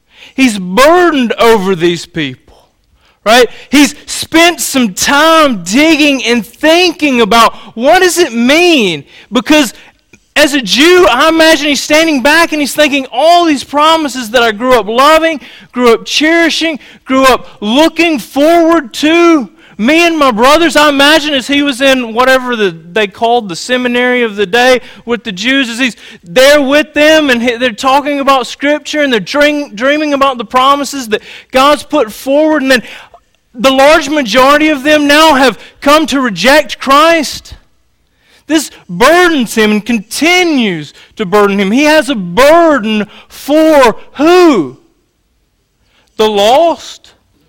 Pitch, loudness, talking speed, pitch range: 275 Hz, -8 LUFS, 150 wpm, 235-305 Hz